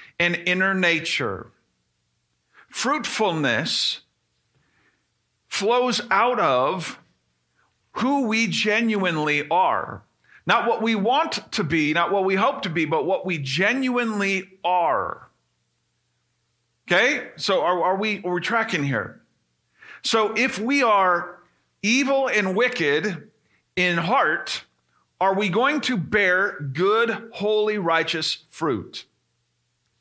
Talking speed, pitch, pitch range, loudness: 110 wpm, 190 Hz, 170-225 Hz, -22 LUFS